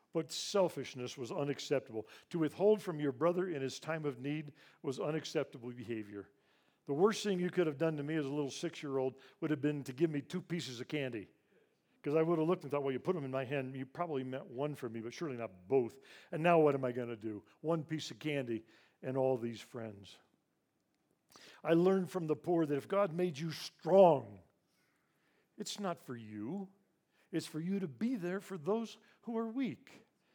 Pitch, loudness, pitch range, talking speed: 150 Hz, -36 LUFS, 130-175 Hz, 215 wpm